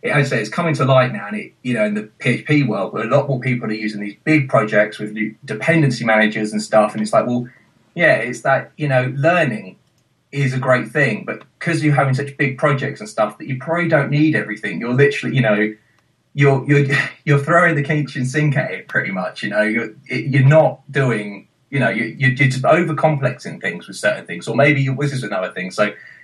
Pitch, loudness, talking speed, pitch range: 135 Hz, -17 LUFS, 225 wpm, 110-150 Hz